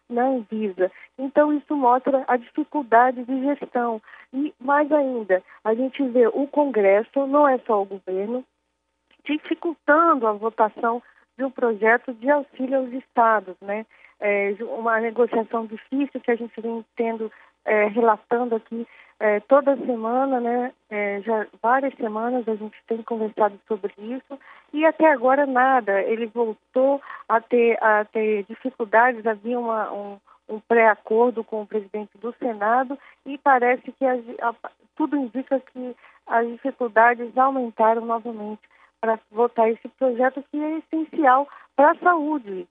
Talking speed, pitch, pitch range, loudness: 130 wpm, 240 Hz, 220-270 Hz, -22 LUFS